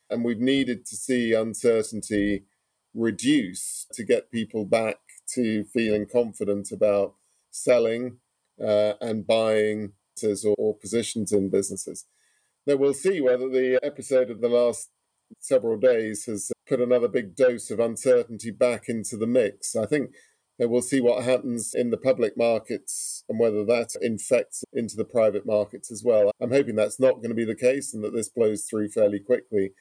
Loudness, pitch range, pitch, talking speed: -25 LUFS, 105-125 Hz, 115 Hz, 165 wpm